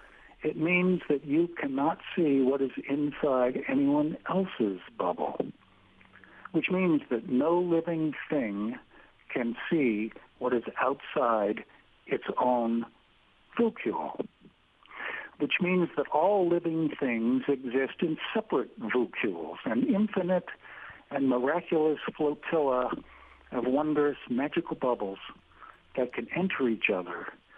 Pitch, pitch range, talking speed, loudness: 155 Hz, 135-185 Hz, 110 wpm, -29 LUFS